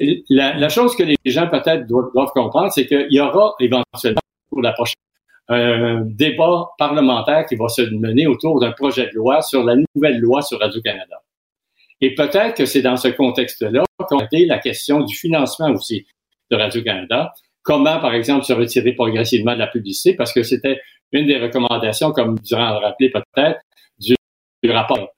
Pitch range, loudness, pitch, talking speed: 120-145 Hz, -17 LUFS, 130 Hz, 180 wpm